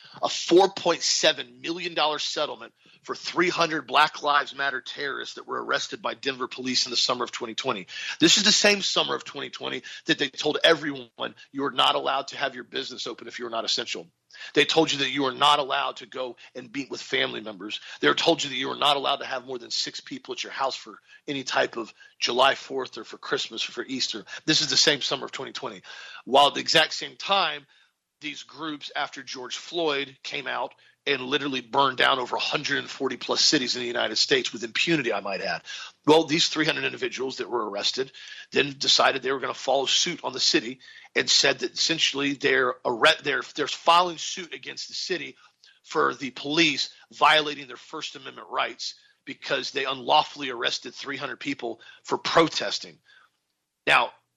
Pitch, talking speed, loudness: 155 Hz, 190 wpm, -24 LUFS